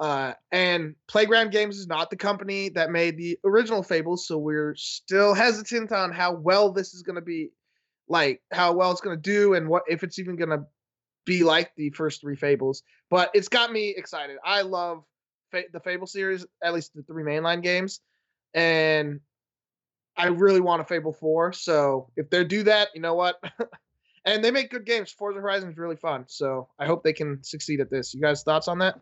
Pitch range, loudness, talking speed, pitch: 155-200 Hz, -25 LUFS, 205 wpm, 175 Hz